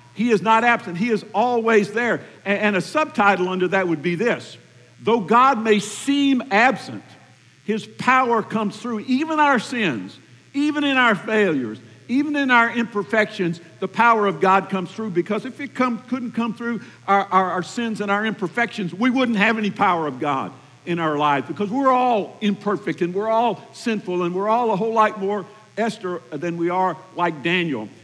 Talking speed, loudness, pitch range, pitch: 185 wpm, -20 LUFS, 185-235 Hz, 210 Hz